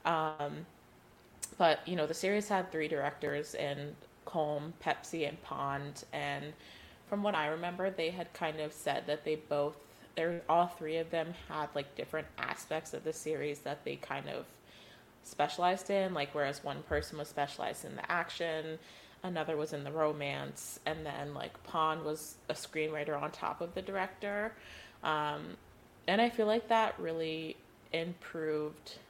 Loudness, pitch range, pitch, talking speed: -36 LUFS, 145-170 Hz, 155 Hz, 165 wpm